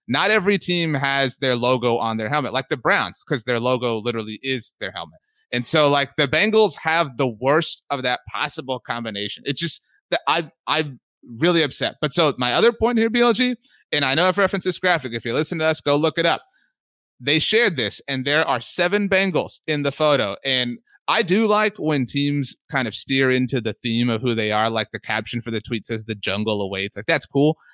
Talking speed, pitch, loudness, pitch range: 220 wpm, 140 Hz, -20 LUFS, 120-165 Hz